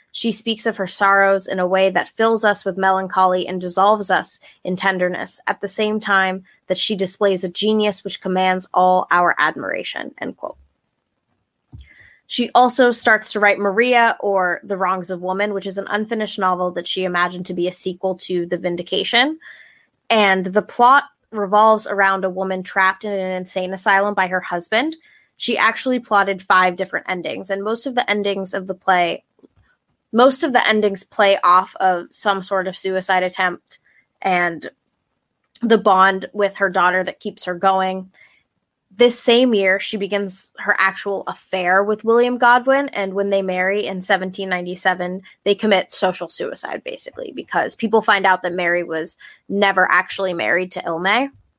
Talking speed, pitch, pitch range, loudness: 170 wpm, 195 Hz, 185-215 Hz, -18 LUFS